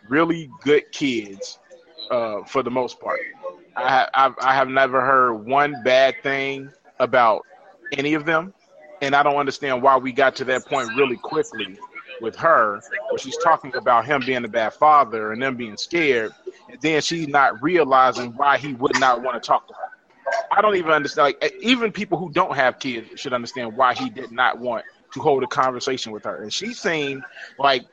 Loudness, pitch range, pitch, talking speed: -20 LUFS, 130-180 Hz, 140 Hz, 195 wpm